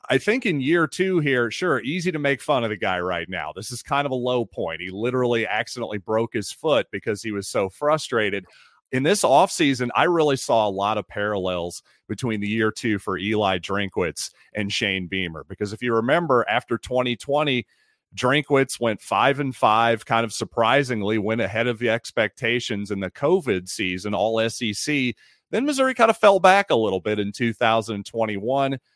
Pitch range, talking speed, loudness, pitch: 105-135 Hz, 185 wpm, -22 LUFS, 115 Hz